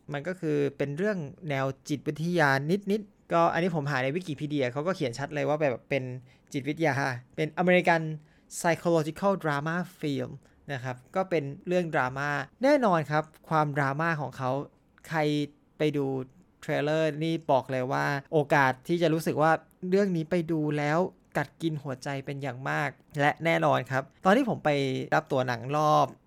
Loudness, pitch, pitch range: -28 LUFS, 150 Hz, 140-165 Hz